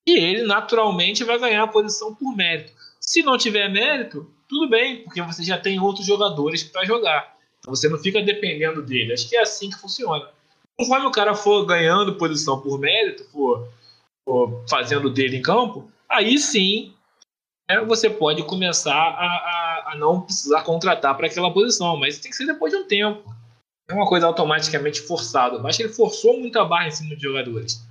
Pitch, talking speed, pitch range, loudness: 175 Hz, 185 wpm, 150-215 Hz, -20 LUFS